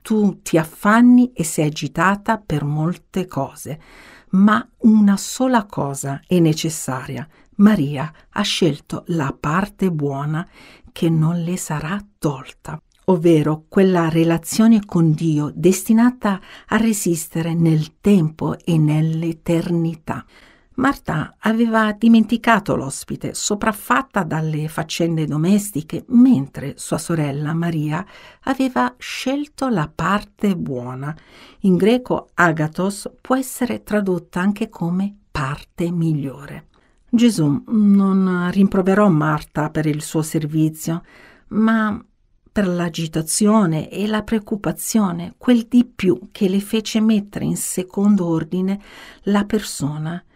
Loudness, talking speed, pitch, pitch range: -19 LUFS, 110 wpm, 180 Hz, 160-215 Hz